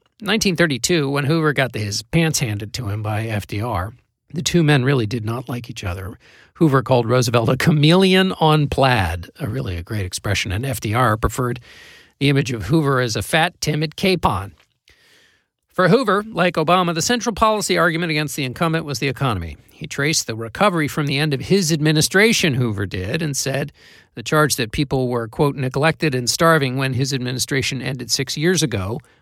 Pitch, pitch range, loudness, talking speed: 140 Hz, 120-165 Hz, -19 LUFS, 185 wpm